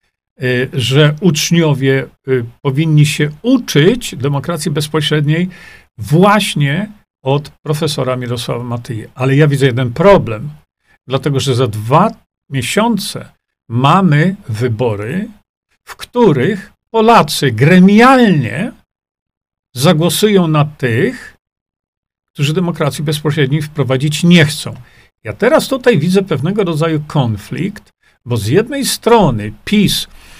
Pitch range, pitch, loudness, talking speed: 130-185 Hz, 155 Hz, -13 LUFS, 95 wpm